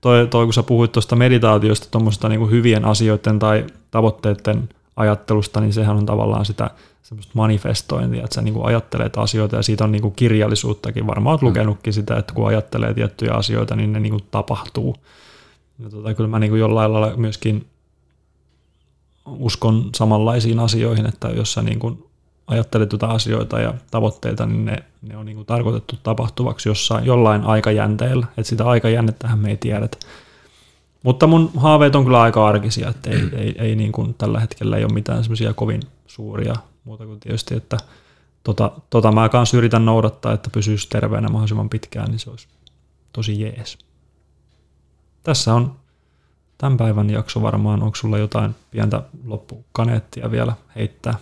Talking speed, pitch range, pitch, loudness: 160 wpm, 105-115 Hz, 110 Hz, -18 LUFS